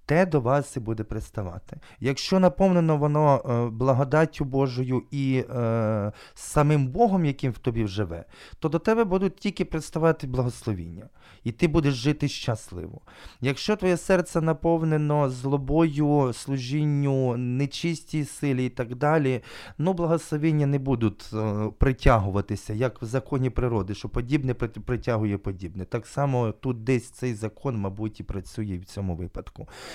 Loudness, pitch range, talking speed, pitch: -26 LUFS, 110-150 Hz, 130 wpm, 135 Hz